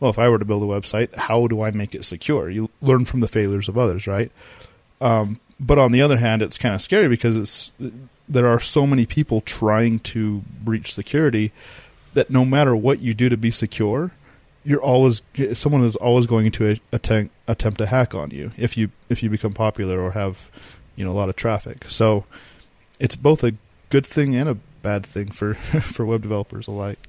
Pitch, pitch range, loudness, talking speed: 115 Hz, 105-125 Hz, -20 LUFS, 210 wpm